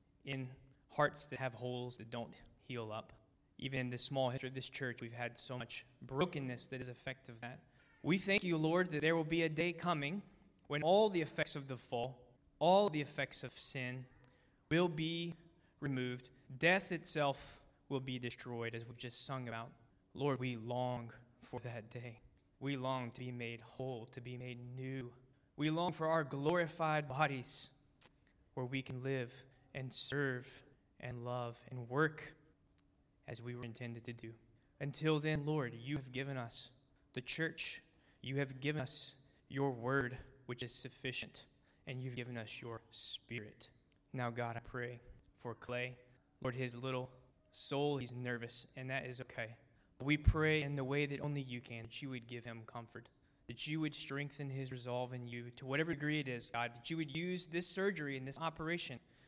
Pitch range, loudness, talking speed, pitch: 120-145 Hz, -40 LUFS, 180 wpm, 130 Hz